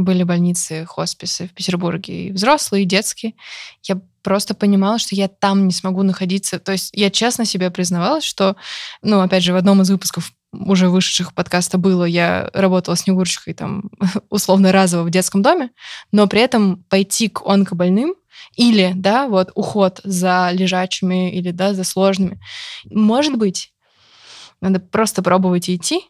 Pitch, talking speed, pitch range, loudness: 190 Hz, 155 wpm, 185-205 Hz, -17 LUFS